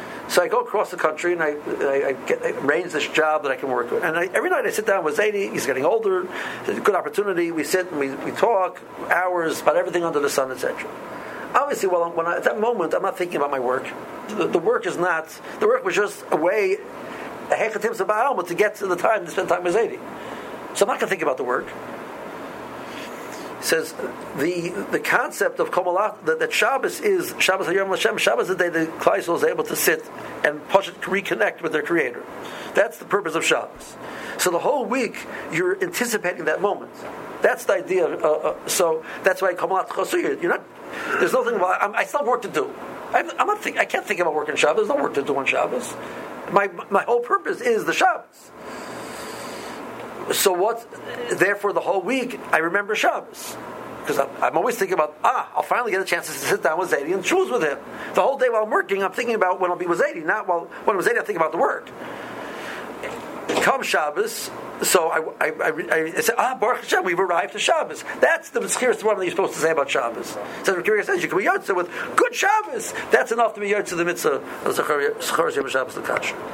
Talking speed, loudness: 225 wpm, -22 LUFS